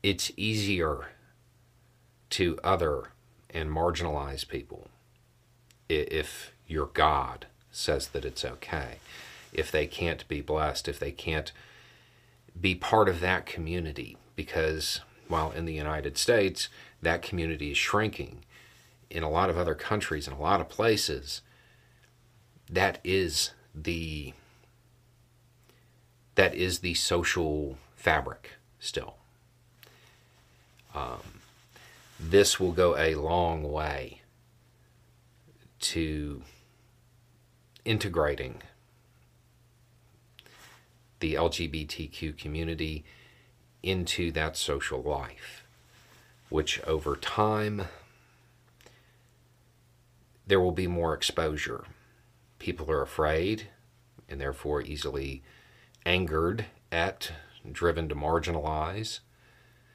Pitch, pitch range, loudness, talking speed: 100 Hz, 80-120 Hz, -30 LUFS, 90 wpm